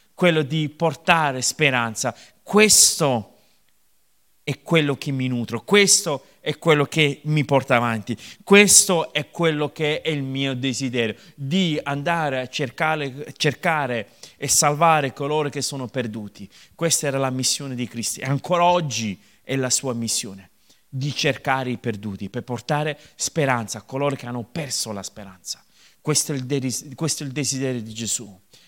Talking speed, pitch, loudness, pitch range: 145 wpm, 140 Hz, -21 LUFS, 120-155 Hz